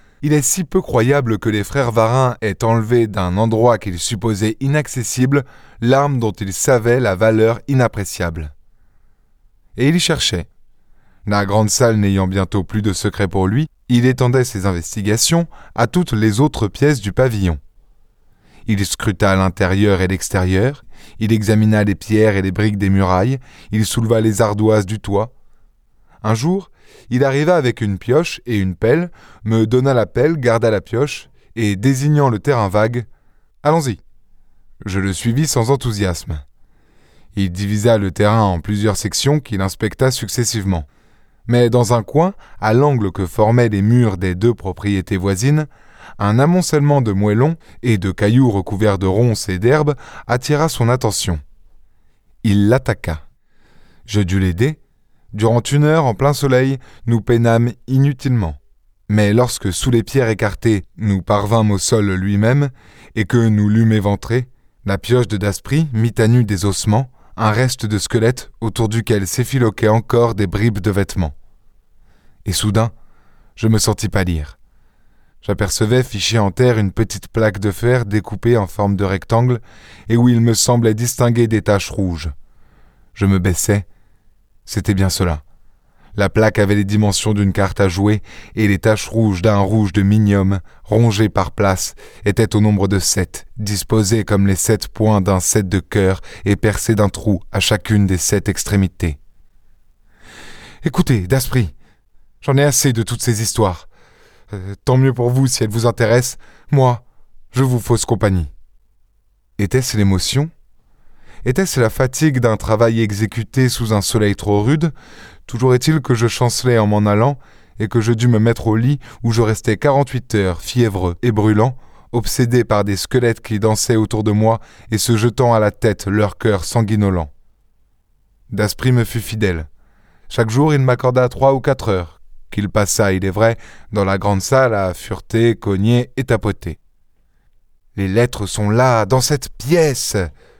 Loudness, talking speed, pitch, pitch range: -16 LUFS, 160 wpm, 110 Hz, 100-120 Hz